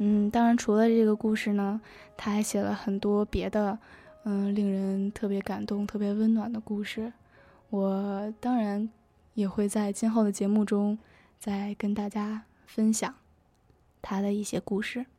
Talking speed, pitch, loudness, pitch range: 225 characters per minute, 210 Hz, -29 LUFS, 200-220 Hz